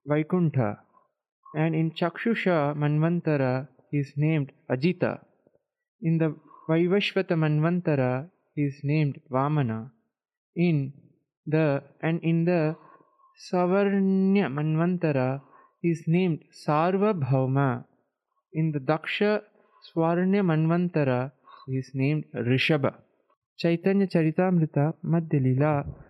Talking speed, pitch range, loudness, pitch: 90 wpm, 145-180 Hz, -26 LUFS, 160 Hz